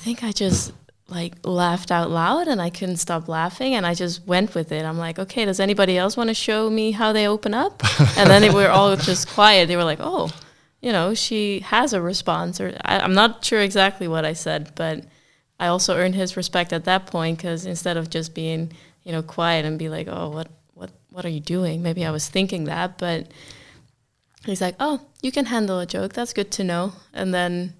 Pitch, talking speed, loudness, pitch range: 180 Hz, 230 wpm, -21 LUFS, 165-200 Hz